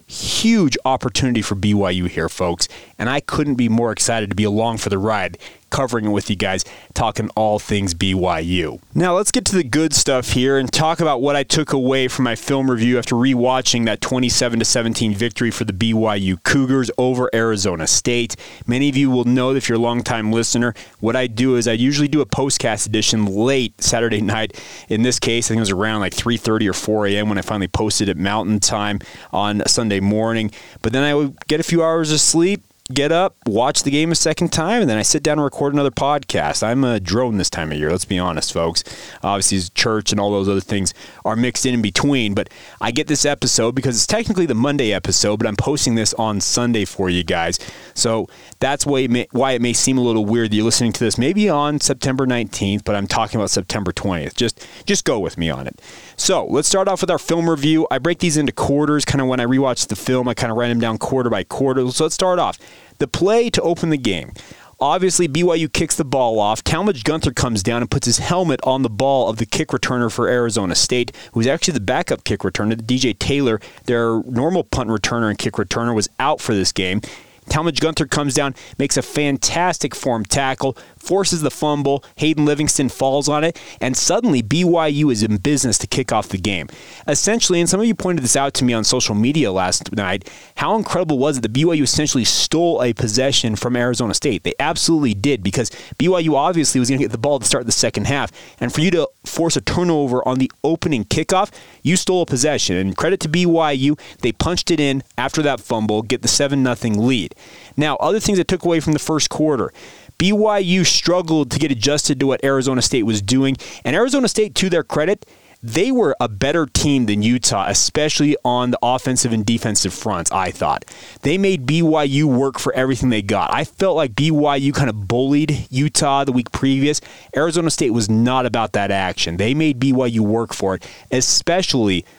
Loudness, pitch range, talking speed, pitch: -18 LUFS, 110-150 Hz, 215 wpm, 130 Hz